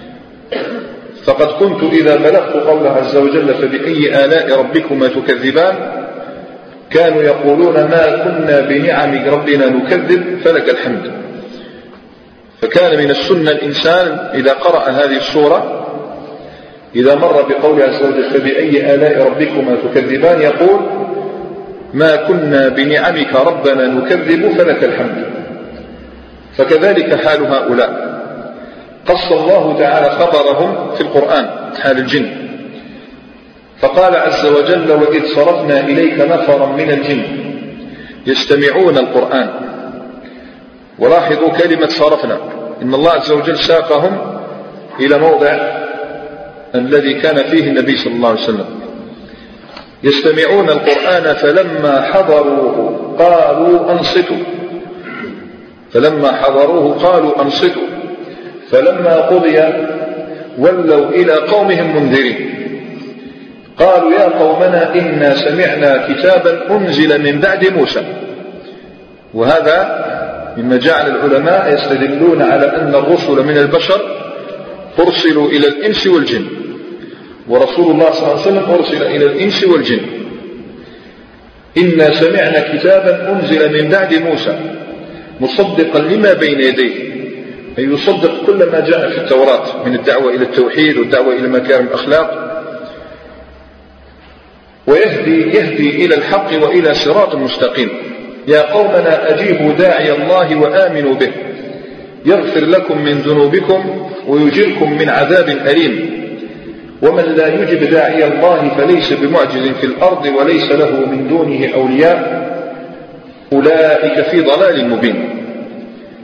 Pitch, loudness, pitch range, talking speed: 155 Hz, -11 LUFS, 140-185 Hz, 105 wpm